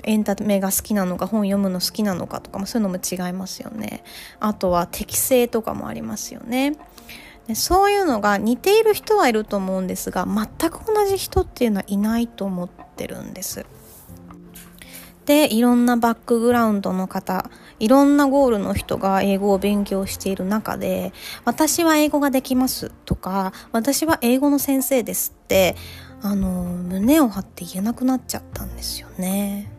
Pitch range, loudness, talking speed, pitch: 190-260 Hz, -20 LUFS, 345 characters per minute, 215 Hz